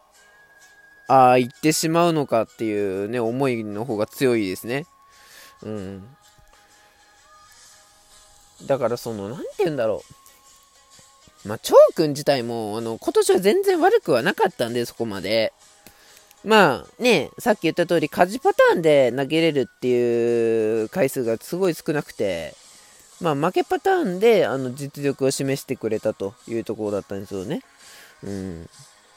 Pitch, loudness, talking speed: 135 Hz, -21 LUFS, 285 characters per minute